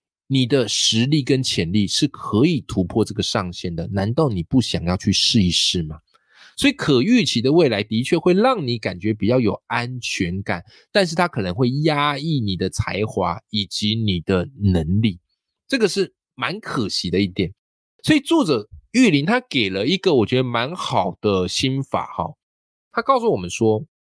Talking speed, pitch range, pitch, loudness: 255 characters per minute, 95-140 Hz, 110 Hz, -20 LUFS